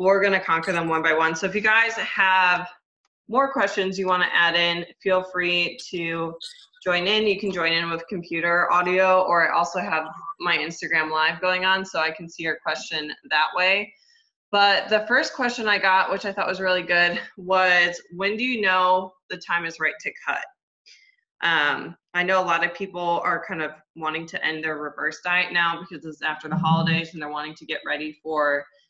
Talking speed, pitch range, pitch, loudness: 210 wpm, 165-190 Hz, 175 Hz, -22 LUFS